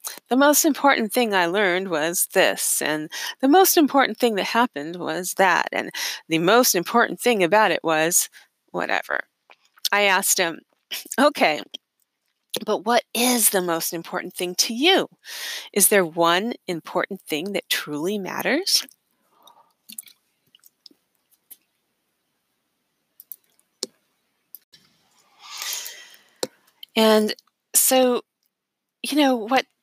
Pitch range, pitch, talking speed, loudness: 180-265 Hz, 220 Hz, 105 wpm, -20 LUFS